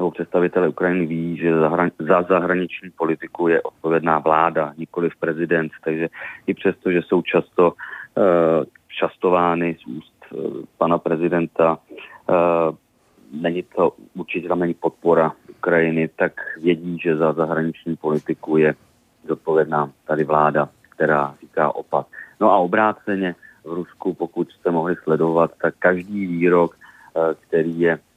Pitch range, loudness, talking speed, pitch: 80-90 Hz, -20 LUFS, 125 wpm, 85 Hz